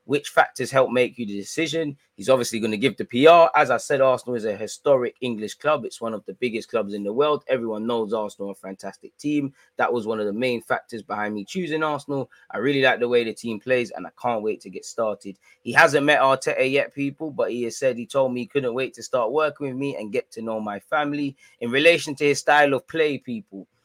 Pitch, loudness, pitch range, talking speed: 125 Hz, -22 LUFS, 110-145 Hz, 250 wpm